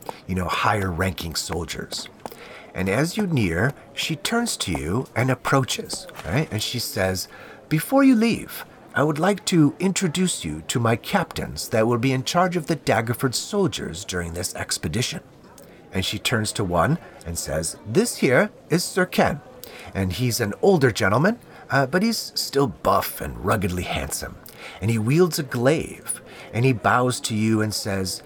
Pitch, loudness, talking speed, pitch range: 120 Hz, -23 LUFS, 170 wpm, 95-160 Hz